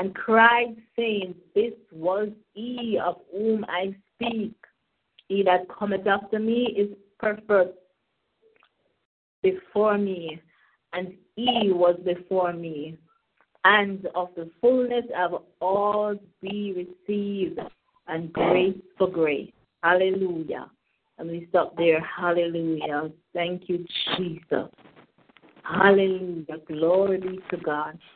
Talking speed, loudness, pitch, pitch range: 105 wpm, -25 LUFS, 185 Hz, 175-210 Hz